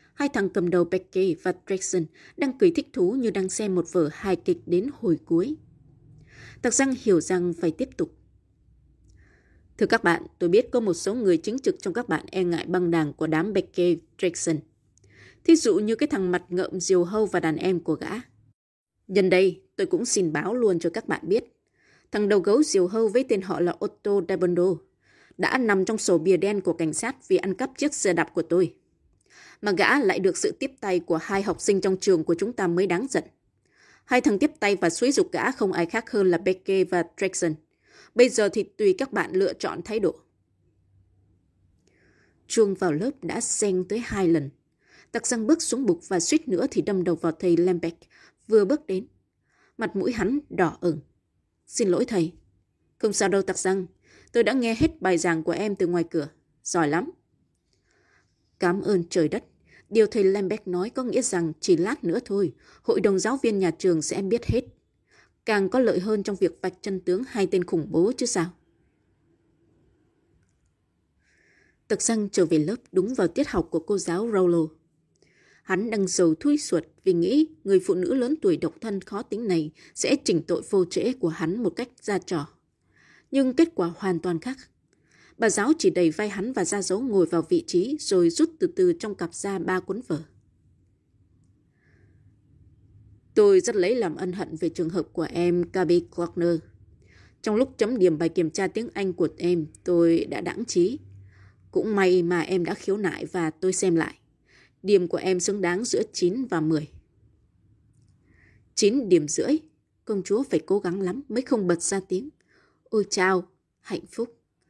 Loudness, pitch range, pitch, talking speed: -25 LUFS, 165-225 Hz, 185 Hz, 195 wpm